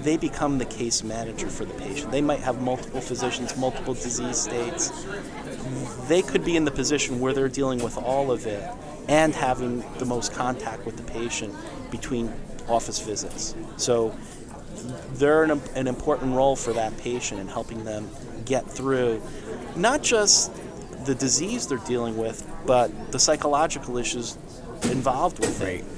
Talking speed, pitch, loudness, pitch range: 160 wpm, 125 Hz, -25 LUFS, 115-135 Hz